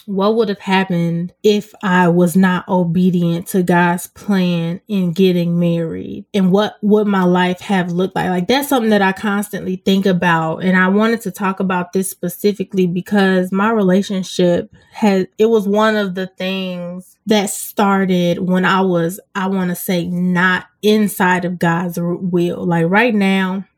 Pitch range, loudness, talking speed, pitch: 180-200 Hz, -16 LUFS, 165 wpm, 185 Hz